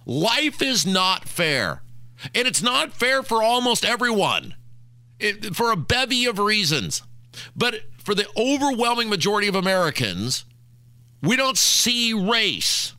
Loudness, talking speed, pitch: -20 LUFS, 130 wpm, 195 Hz